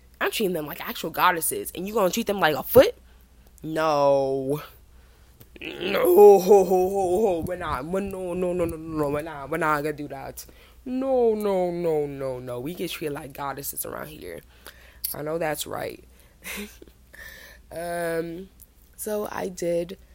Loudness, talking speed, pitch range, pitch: -24 LUFS, 160 wpm, 150-195 Hz, 170 Hz